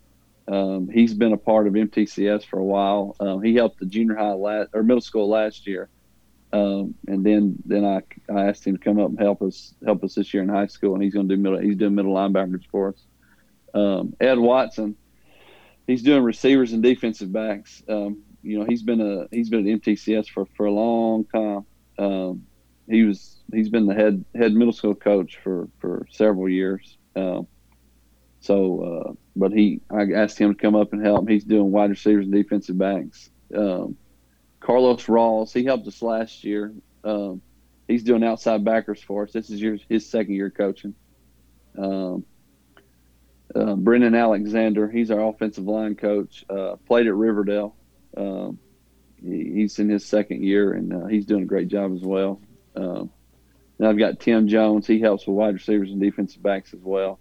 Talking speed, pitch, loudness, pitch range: 190 wpm, 105 Hz, -22 LUFS, 95-110 Hz